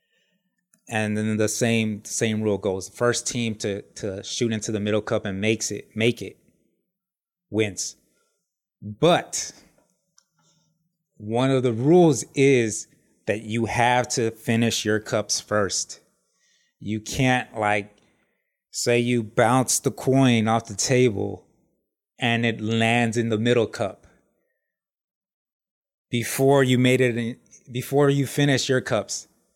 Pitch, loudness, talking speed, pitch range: 120 Hz, -23 LUFS, 130 wpm, 110-135 Hz